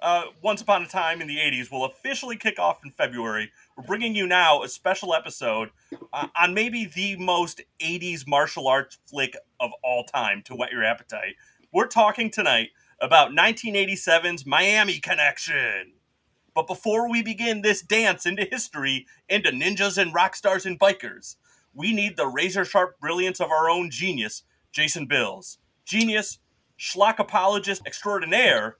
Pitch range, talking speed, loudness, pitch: 165-210 Hz, 155 wpm, -23 LUFS, 190 Hz